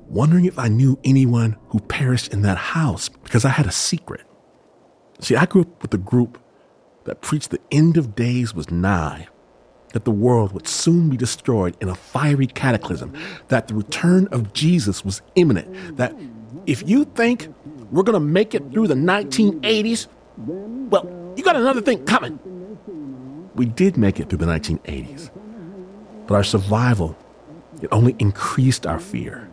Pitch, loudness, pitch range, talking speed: 130 Hz, -19 LUFS, 105-180 Hz, 165 wpm